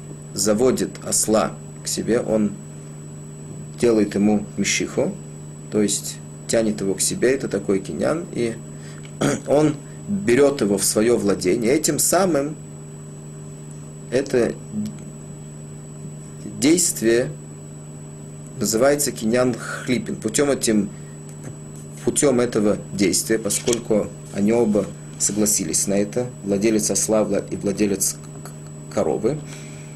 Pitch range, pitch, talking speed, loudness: 75-110 Hz, 75 Hz, 95 wpm, -20 LUFS